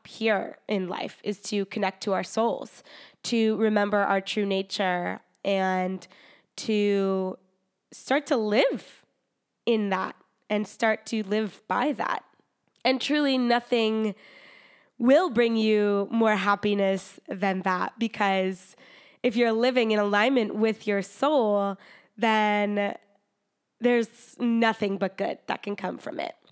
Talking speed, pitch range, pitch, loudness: 125 wpm, 195-230 Hz, 210 Hz, -26 LUFS